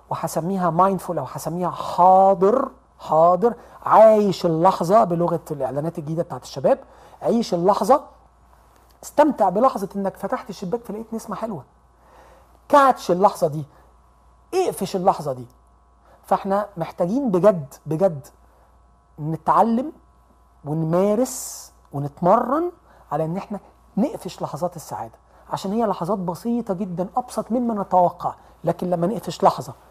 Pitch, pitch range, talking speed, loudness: 190 Hz, 165-220 Hz, 110 wpm, -21 LUFS